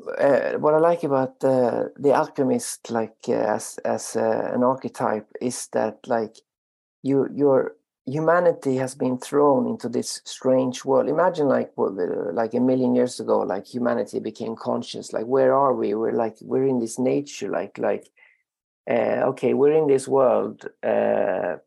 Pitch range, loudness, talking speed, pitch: 125-155 Hz, -23 LUFS, 160 wpm, 130 Hz